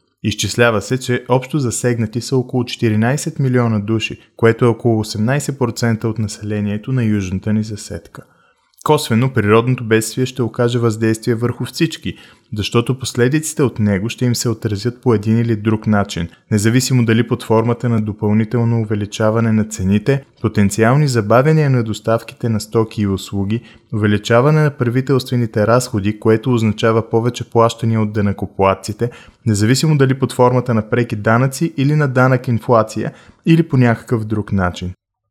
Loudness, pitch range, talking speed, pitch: -16 LUFS, 110-125 Hz, 145 wpm, 115 Hz